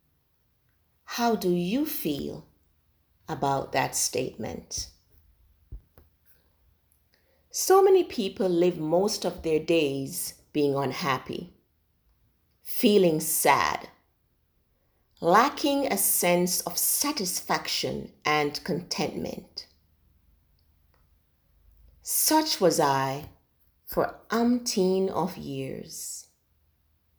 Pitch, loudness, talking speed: 140 Hz, -26 LUFS, 75 wpm